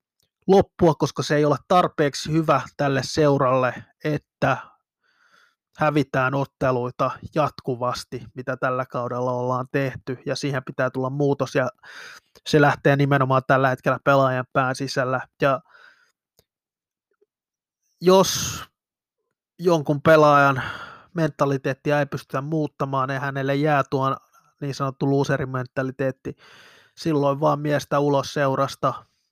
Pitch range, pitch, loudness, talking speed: 130-150 Hz, 140 Hz, -22 LUFS, 105 wpm